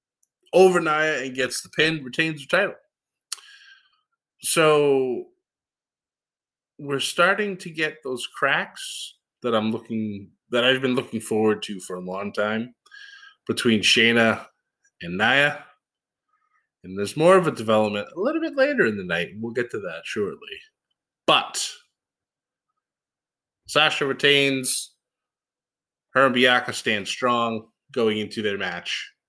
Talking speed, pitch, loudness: 130 wpm, 135 Hz, -22 LUFS